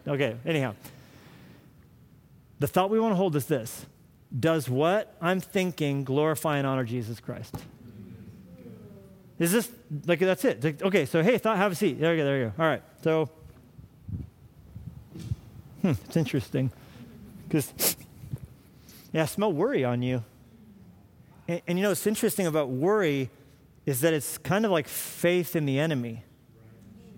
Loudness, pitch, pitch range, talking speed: -27 LUFS, 150 Hz, 130-175 Hz, 150 wpm